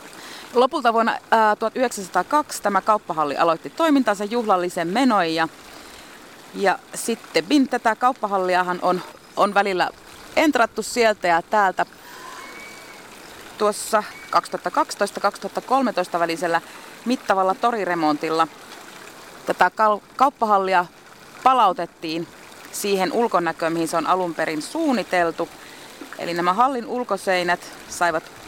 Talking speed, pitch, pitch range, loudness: 90 wpm, 195 Hz, 175-230 Hz, -21 LUFS